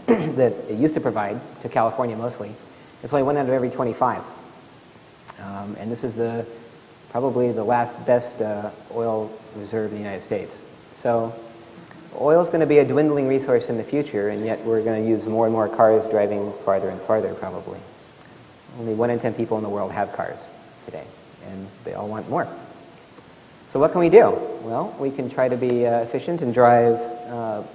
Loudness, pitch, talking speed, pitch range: -22 LUFS, 115 Hz, 195 wpm, 110-125 Hz